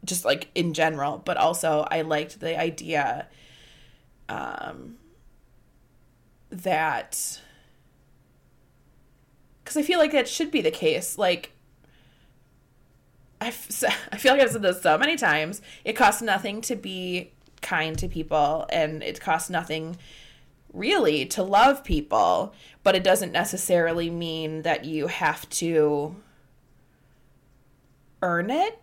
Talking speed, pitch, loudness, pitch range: 125 wpm, 165 Hz, -24 LUFS, 145-195 Hz